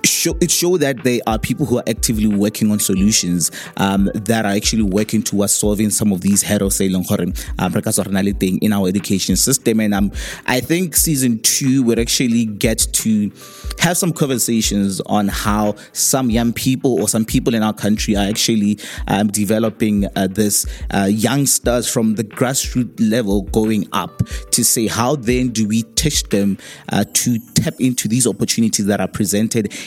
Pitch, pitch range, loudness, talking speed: 110 Hz, 100-120 Hz, -16 LUFS, 170 wpm